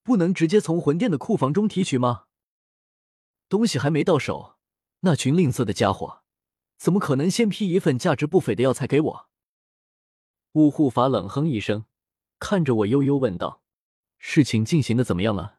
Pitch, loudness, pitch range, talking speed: 145 Hz, -22 LUFS, 120-180 Hz, 260 characters per minute